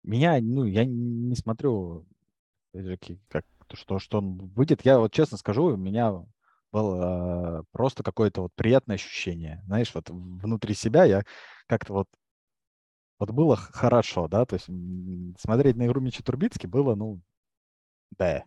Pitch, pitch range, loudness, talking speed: 105 Hz, 90-120 Hz, -26 LUFS, 135 wpm